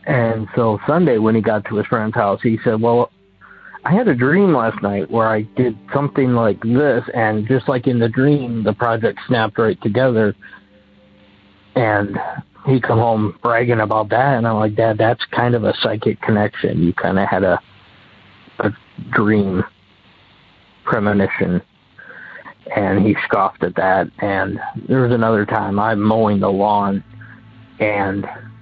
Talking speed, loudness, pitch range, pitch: 160 wpm, -17 LUFS, 105-120 Hz, 110 Hz